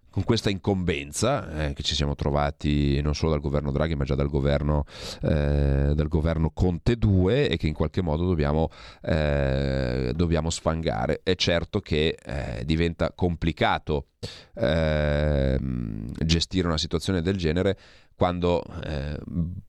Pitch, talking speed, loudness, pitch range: 80 Hz, 135 wpm, -25 LUFS, 75-90 Hz